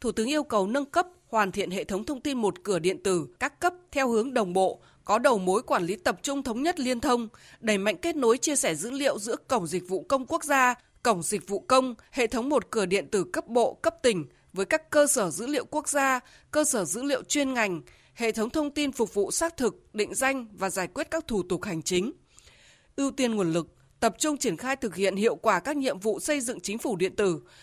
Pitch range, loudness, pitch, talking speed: 200-280 Hz, -27 LUFS, 235 Hz, 250 wpm